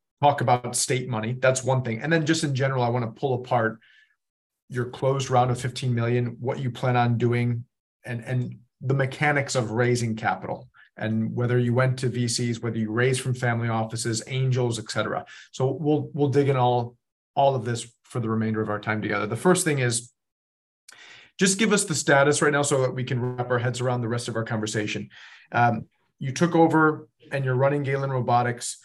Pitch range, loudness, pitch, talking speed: 115-135 Hz, -24 LUFS, 125 Hz, 205 wpm